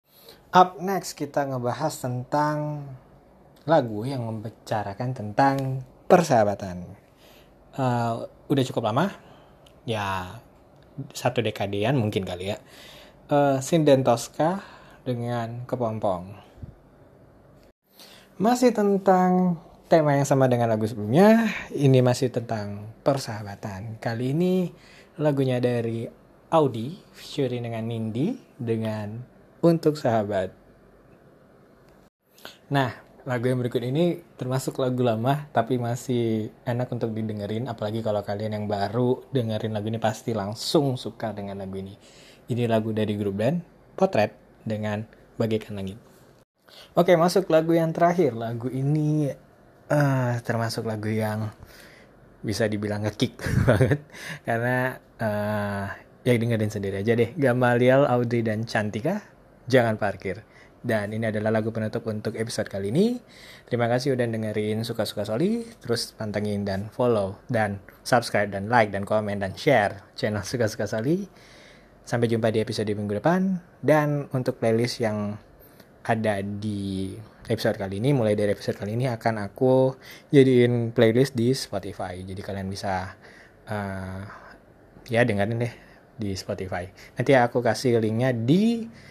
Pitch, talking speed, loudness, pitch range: 120 Hz, 120 wpm, -25 LUFS, 105-135 Hz